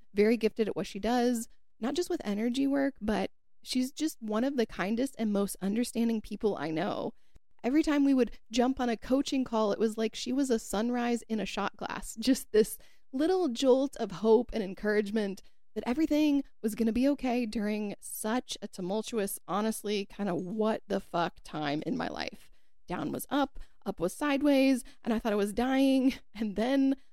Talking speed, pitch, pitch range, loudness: 190 wpm, 225 Hz, 210-265 Hz, -31 LUFS